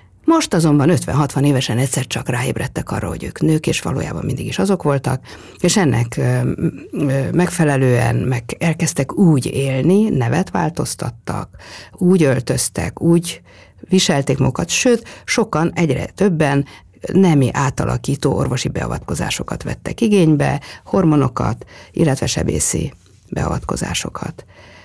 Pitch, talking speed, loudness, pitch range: 150 Hz, 110 wpm, -17 LUFS, 130-175 Hz